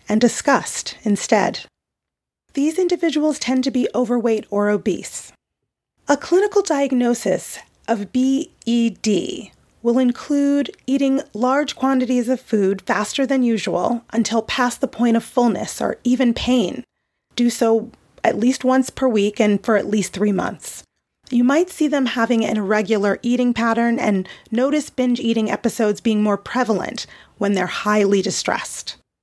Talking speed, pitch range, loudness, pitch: 140 wpm, 210-260 Hz, -19 LUFS, 235 Hz